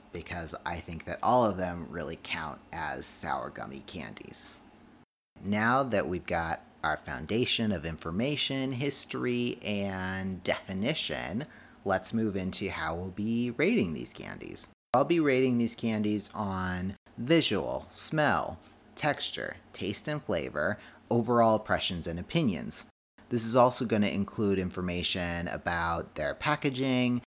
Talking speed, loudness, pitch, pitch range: 125 wpm, -30 LUFS, 105 Hz, 90-120 Hz